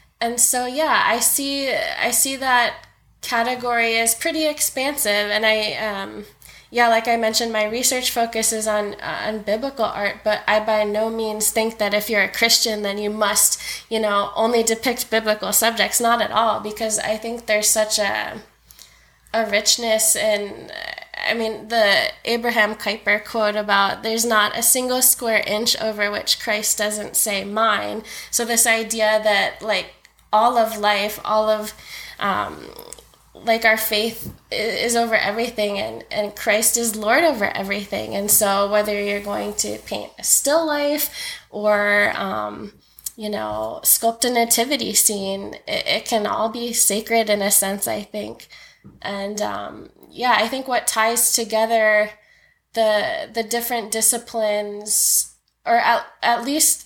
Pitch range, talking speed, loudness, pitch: 210-235 Hz, 155 wpm, -19 LUFS, 220 Hz